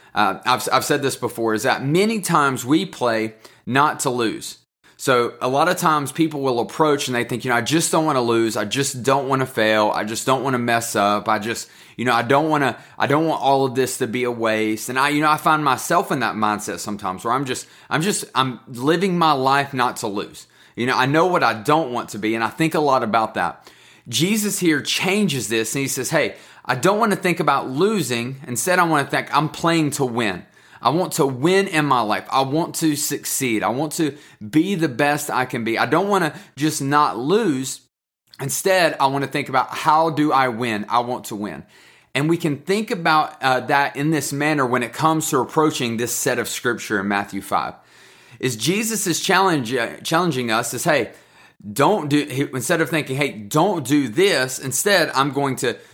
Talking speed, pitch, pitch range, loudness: 230 wpm, 140 Hz, 120-155 Hz, -20 LUFS